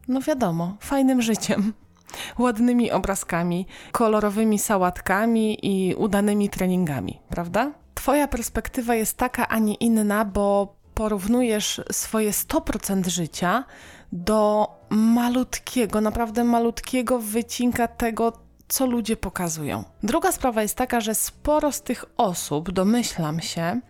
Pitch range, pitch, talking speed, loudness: 195-240 Hz, 220 Hz, 110 wpm, -23 LUFS